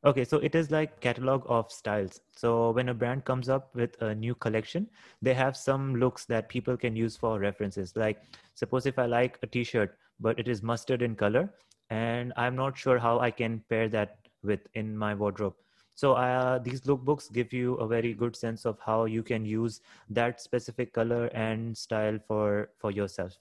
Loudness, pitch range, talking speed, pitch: -30 LUFS, 110-125 Hz, 200 wpm, 120 Hz